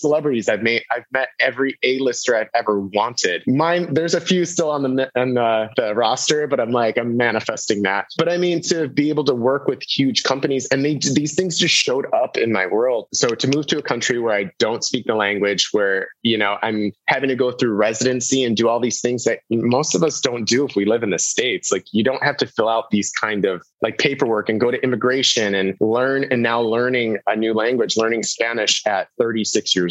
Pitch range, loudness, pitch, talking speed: 110-145 Hz, -19 LUFS, 125 Hz, 230 wpm